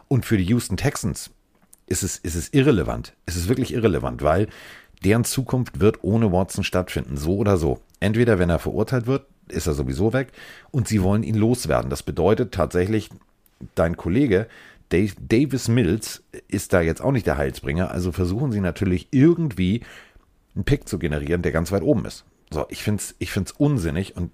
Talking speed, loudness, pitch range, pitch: 185 wpm, -22 LUFS, 85-120 Hz, 100 Hz